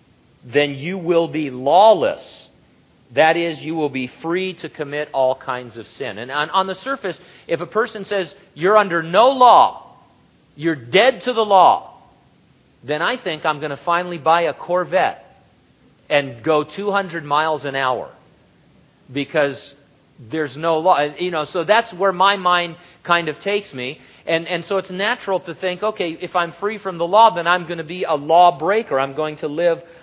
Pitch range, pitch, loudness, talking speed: 150-190 Hz, 170 Hz, -18 LUFS, 180 wpm